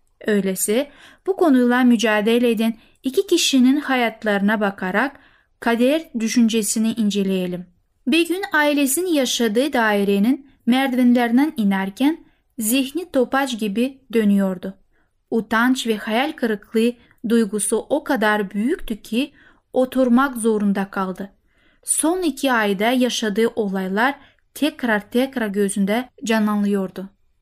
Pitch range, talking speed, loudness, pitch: 210-270 Hz, 95 wpm, -19 LUFS, 235 Hz